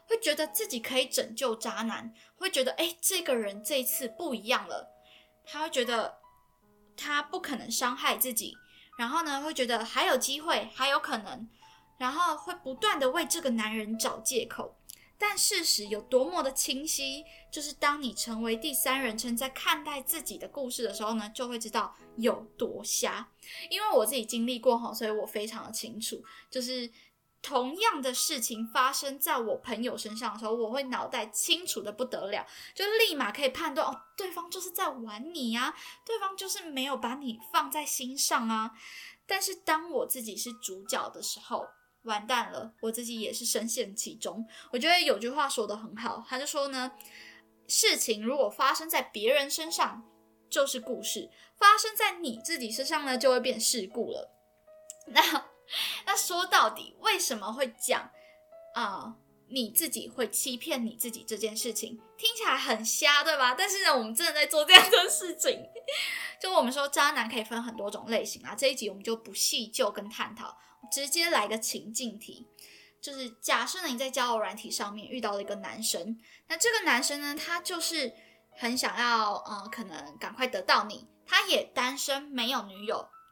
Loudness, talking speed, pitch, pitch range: -29 LUFS, 270 characters per minute, 255 Hz, 225-310 Hz